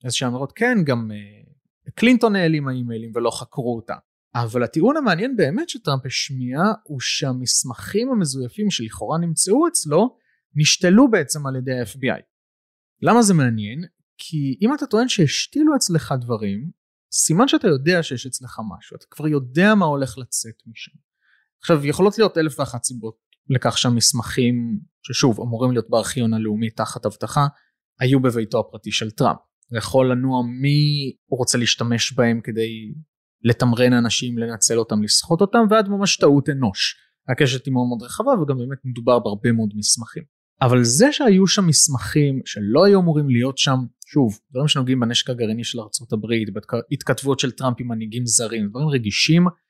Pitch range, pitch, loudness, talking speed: 120-160 Hz, 130 Hz, -19 LUFS, 155 wpm